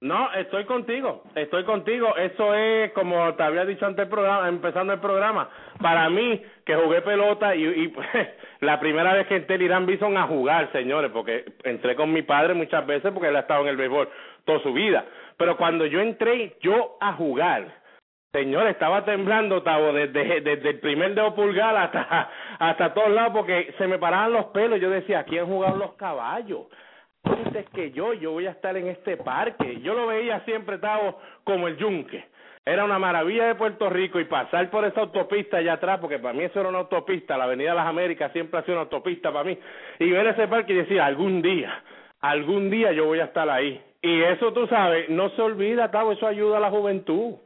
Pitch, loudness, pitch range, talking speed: 190 Hz, -23 LUFS, 165-215 Hz, 210 wpm